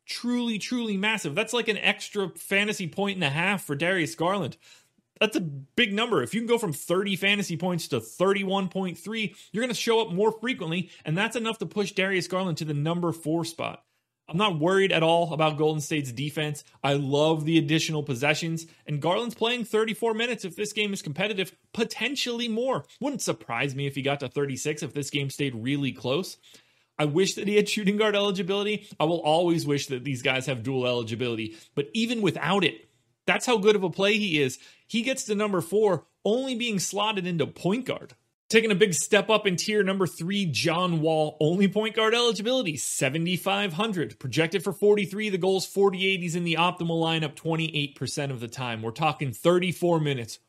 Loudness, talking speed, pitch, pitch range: -26 LUFS, 205 wpm, 180 Hz, 150-210 Hz